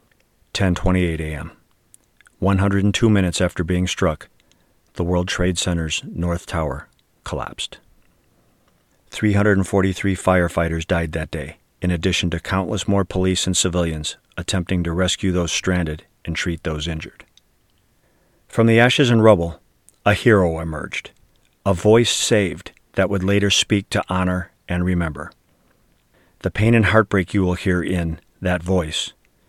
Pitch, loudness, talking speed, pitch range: 90 Hz, -20 LUFS, 130 wpm, 85-100 Hz